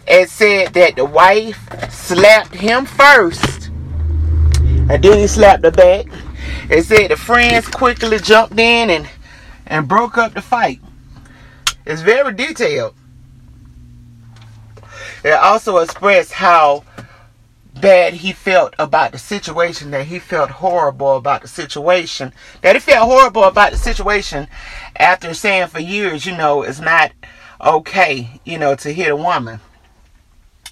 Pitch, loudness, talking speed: 165 Hz, -12 LUFS, 135 wpm